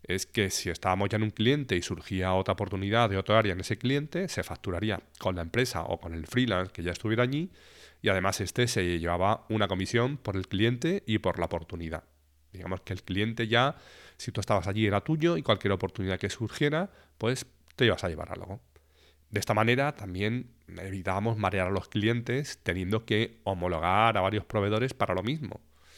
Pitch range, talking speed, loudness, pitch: 95-115 Hz, 195 wpm, -29 LUFS, 100 Hz